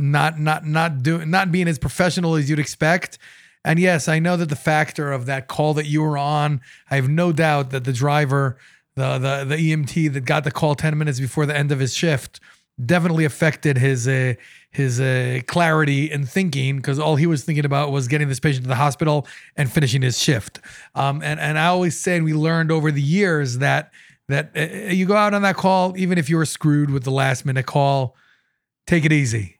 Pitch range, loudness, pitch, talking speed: 140-160 Hz, -20 LUFS, 150 Hz, 220 wpm